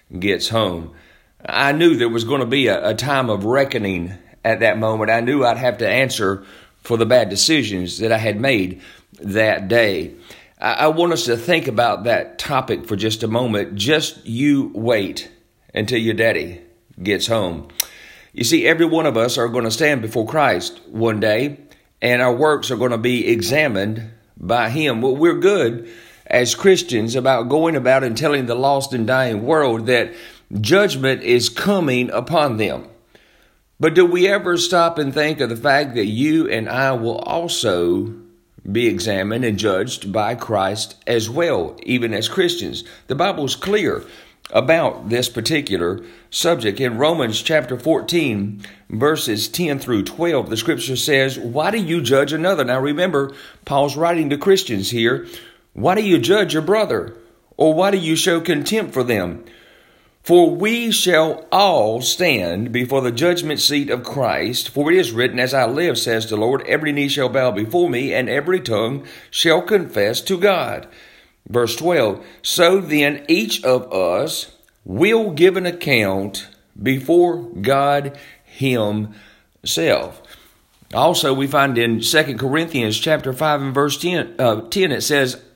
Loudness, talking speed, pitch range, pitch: -18 LUFS, 165 wpm, 115-160 Hz, 130 Hz